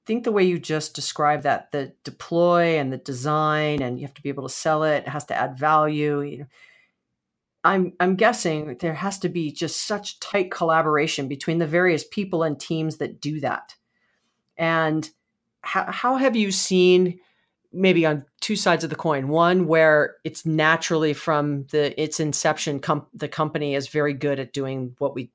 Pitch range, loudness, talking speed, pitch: 145-175 Hz, -22 LUFS, 185 wpm, 155 Hz